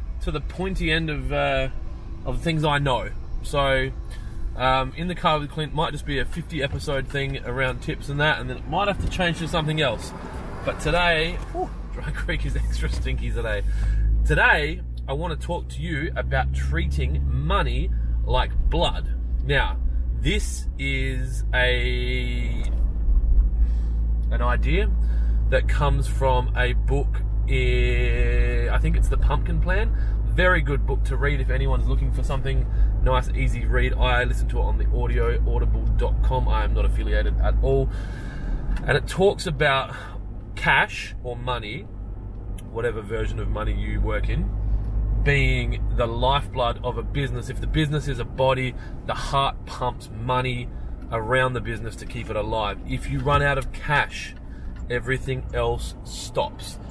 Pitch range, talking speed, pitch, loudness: 100-135 Hz, 155 wpm, 120 Hz, -24 LUFS